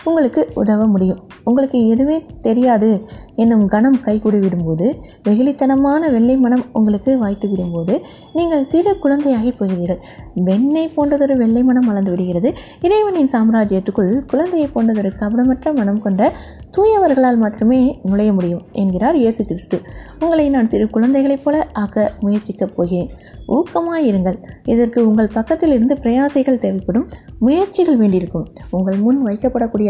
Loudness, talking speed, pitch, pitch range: -16 LUFS, 120 wpm, 235 Hz, 205-275 Hz